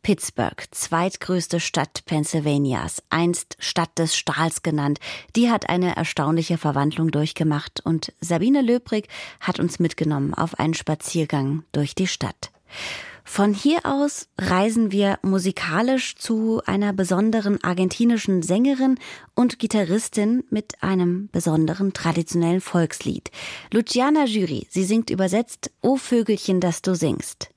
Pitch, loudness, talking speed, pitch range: 185 Hz, -22 LUFS, 120 wpm, 160-220 Hz